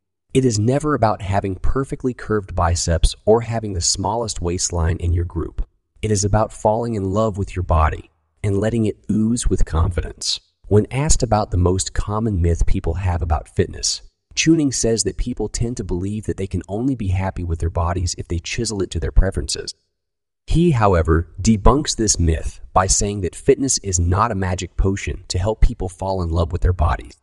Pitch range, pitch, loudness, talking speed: 85-110 Hz, 95 Hz, -20 LUFS, 195 wpm